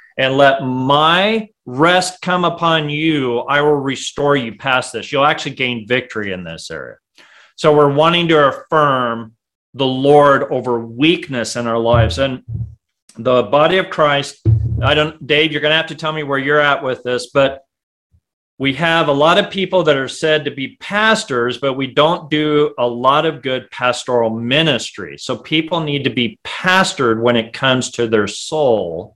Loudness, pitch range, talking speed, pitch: -15 LUFS, 125-155 Hz, 180 wpm, 140 Hz